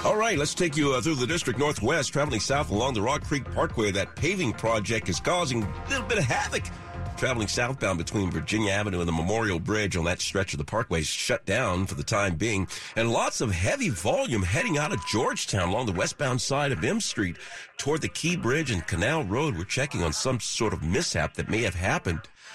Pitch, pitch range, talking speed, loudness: 105 Hz, 90-130 Hz, 220 wpm, -27 LUFS